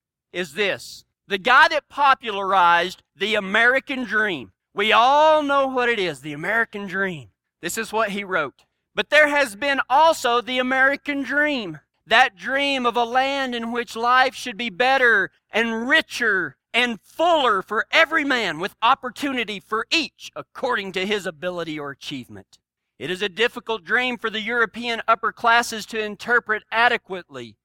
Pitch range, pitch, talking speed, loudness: 200-265 Hz, 230 Hz, 155 wpm, -20 LUFS